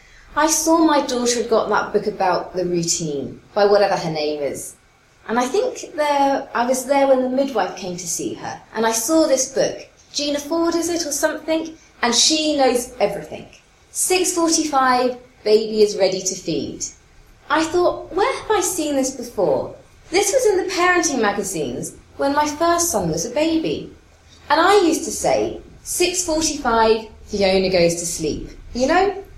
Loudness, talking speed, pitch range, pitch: -19 LUFS, 170 wpm, 210-330 Hz, 275 Hz